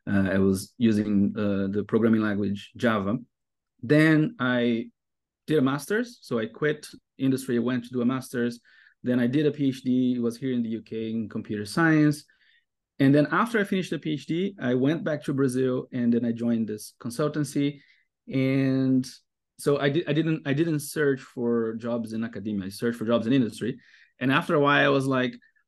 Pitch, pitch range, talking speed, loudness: 130 Hz, 115-150 Hz, 185 wpm, -26 LUFS